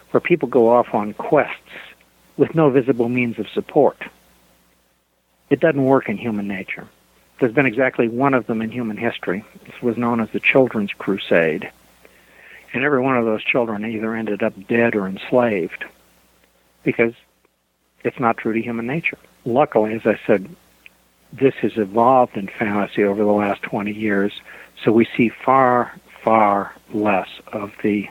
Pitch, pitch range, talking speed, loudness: 110 Hz, 100-125 Hz, 160 wpm, -19 LUFS